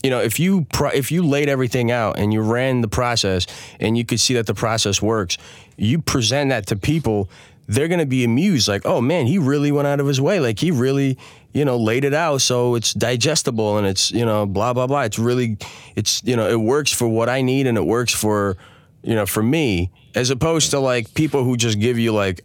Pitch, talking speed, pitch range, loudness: 120 Hz, 240 wpm, 110-140 Hz, -19 LUFS